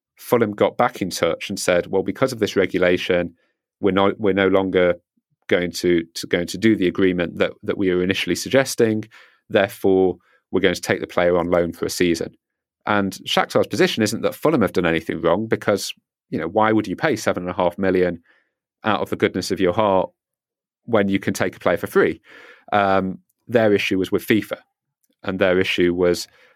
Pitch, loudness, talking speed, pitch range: 95 Hz, -20 LUFS, 205 wpm, 90-100 Hz